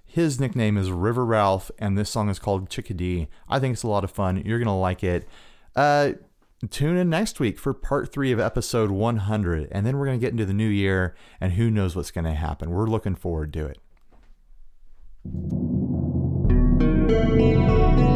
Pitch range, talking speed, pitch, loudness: 85-115 Hz, 185 wpm, 100 Hz, -24 LUFS